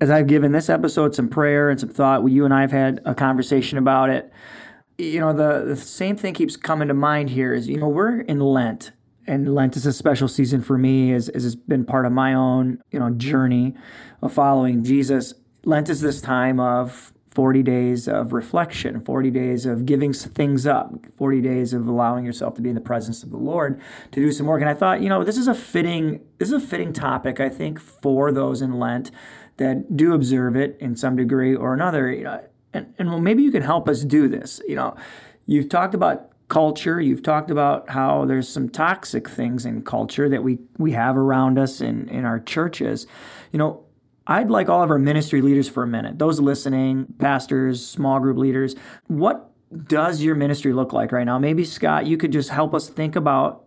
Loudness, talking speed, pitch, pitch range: -20 LUFS, 215 wpm, 135 Hz, 130-150 Hz